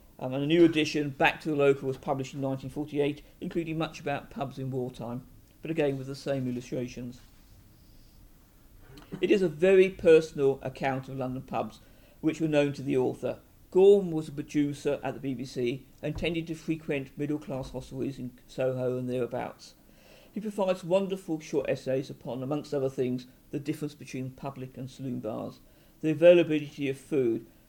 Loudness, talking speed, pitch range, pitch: -29 LUFS, 170 wpm, 130-155 Hz, 140 Hz